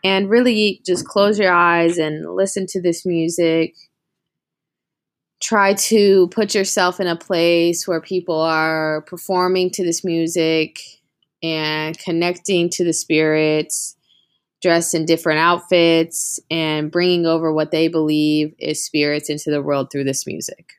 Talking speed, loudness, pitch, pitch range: 140 wpm, -18 LUFS, 170 Hz, 155-180 Hz